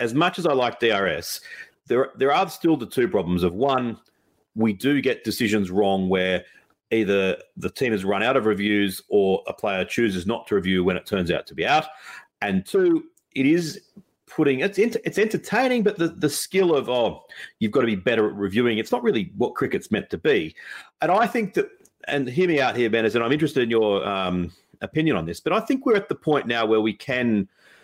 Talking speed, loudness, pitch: 220 wpm, -23 LUFS, 135 Hz